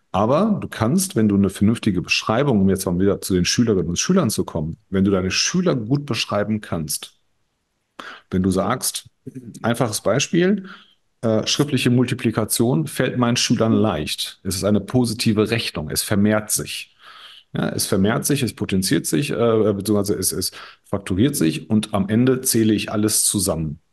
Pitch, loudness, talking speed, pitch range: 110 Hz, -20 LUFS, 165 wpm, 100-125 Hz